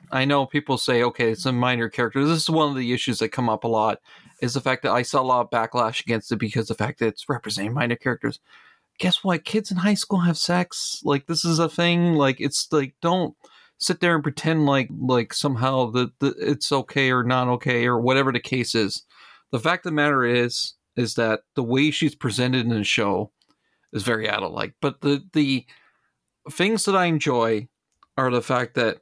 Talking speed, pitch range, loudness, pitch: 220 wpm, 120-155 Hz, -22 LUFS, 130 Hz